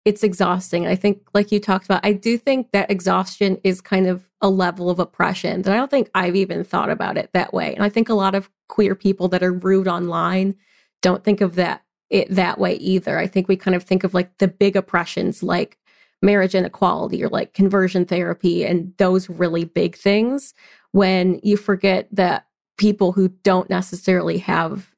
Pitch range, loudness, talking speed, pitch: 185-200 Hz, -19 LUFS, 200 wpm, 190 Hz